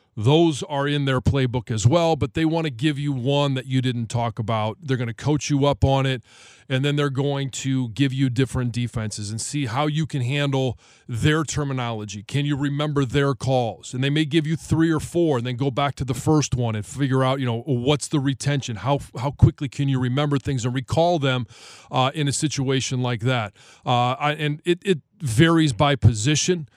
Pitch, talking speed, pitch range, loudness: 135 Hz, 215 wpm, 125-145 Hz, -22 LUFS